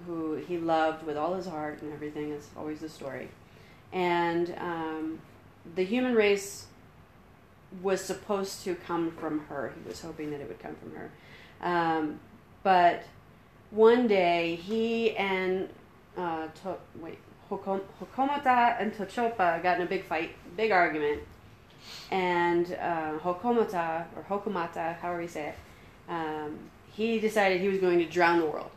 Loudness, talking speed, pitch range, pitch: -29 LUFS, 150 wpm, 155-190 Hz, 175 Hz